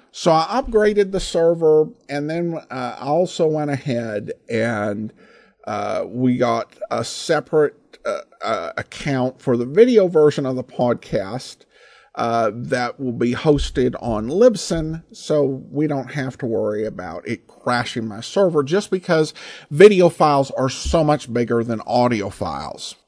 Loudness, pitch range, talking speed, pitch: -19 LUFS, 120-165 Hz, 150 wpm, 140 Hz